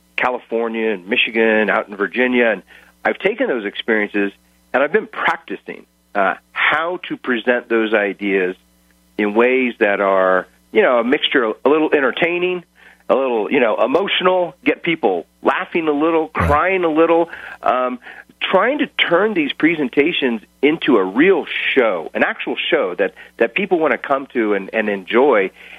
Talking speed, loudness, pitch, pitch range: 160 wpm, -17 LUFS, 120 Hz, 100-165 Hz